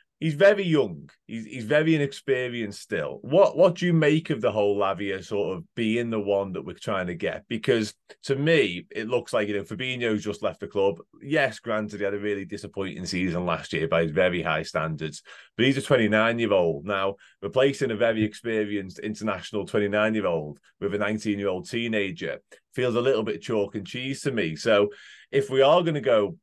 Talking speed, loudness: 195 wpm, -25 LUFS